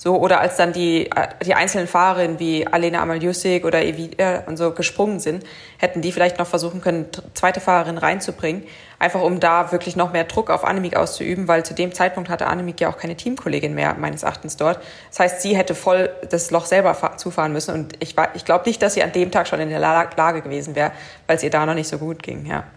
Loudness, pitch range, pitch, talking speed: -20 LUFS, 160-180 Hz, 170 Hz, 230 wpm